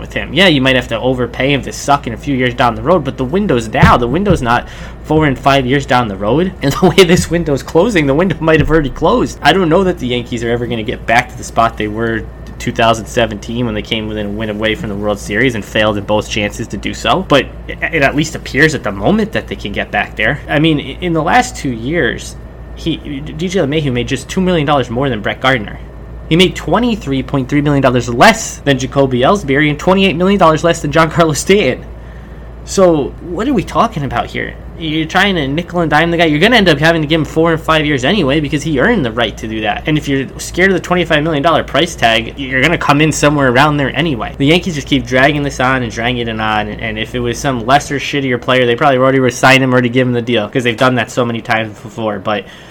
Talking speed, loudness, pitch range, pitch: 260 wpm, -13 LUFS, 115-160 Hz, 135 Hz